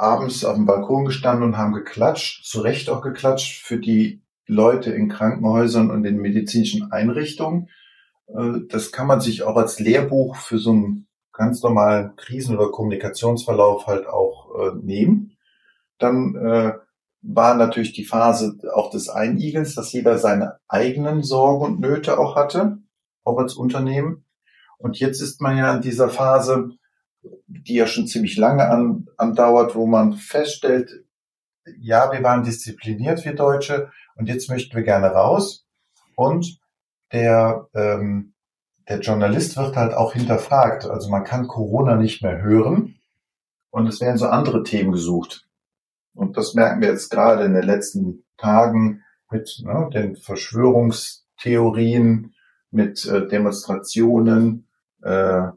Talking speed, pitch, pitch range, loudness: 140 wpm, 115 Hz, 110-135 Hz, -19 LUFS